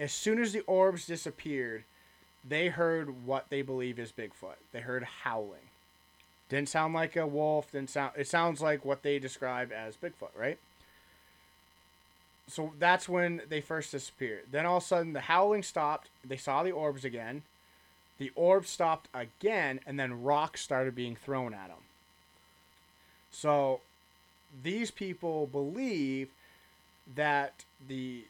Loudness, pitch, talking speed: -33 LUFS, 135 Hz, 145 wpm